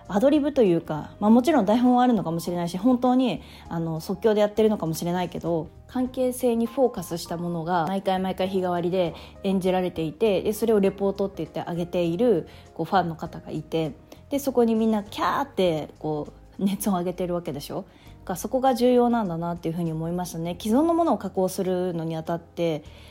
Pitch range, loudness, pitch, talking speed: 170-225 Hz, -25 LUFS, 185 Hz, 395 characters per minute